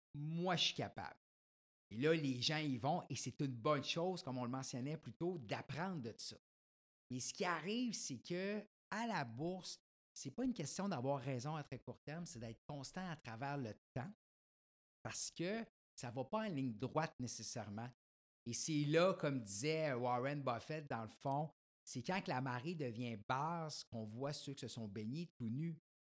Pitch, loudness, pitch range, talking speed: 140 Hz, -43 LUFS, 125-170 Hz, 195 wpm